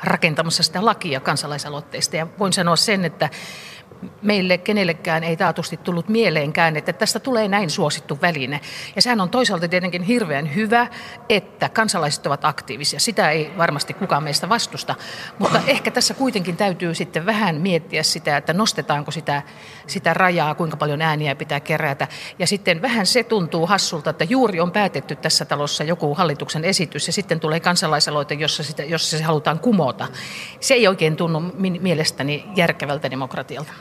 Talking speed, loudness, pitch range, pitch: 160 wpm, -20 LUFS, 155-195 Hz, 170 Hz